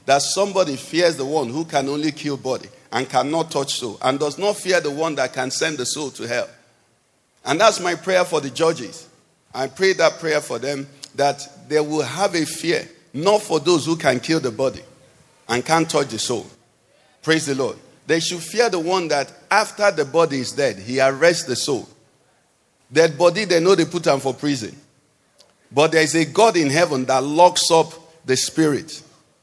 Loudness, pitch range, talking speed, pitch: -20 LUFS, 140-170 Hz, 200 wpm, 155 Hz